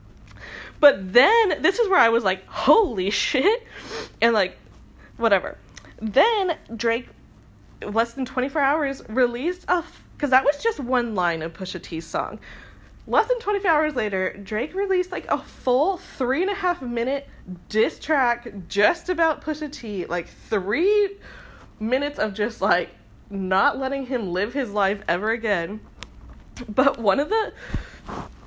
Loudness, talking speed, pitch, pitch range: -23 LUFS, 155 wpm, 255 Hz, 210-335 Hz